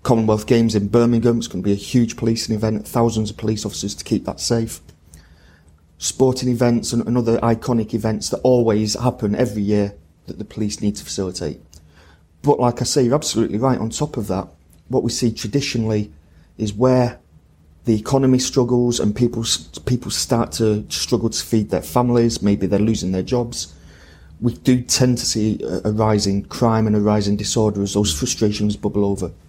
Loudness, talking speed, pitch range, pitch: -19 LUFS, 175 wpm, 95-120 Hz, 110 Hz